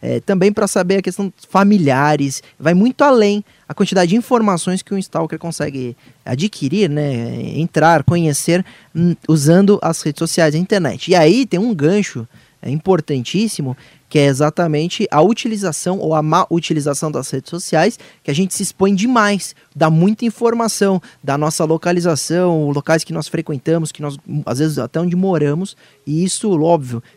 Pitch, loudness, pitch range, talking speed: 165 Hz, -16 LUFS, 150-195 Hz, 165 wpm